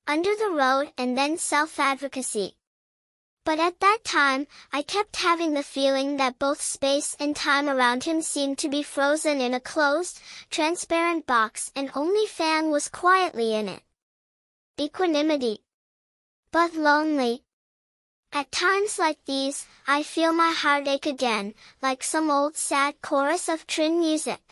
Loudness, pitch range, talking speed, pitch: -24 LUFS, 275-325 Hz, 140 wpm, 290 Hz